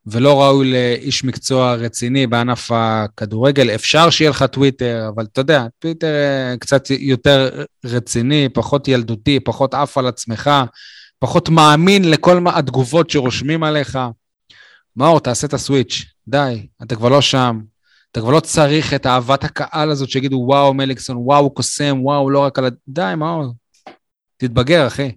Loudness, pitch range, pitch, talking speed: -15 LUFS, 125-145 Hz, 135 Hz, 150 wpm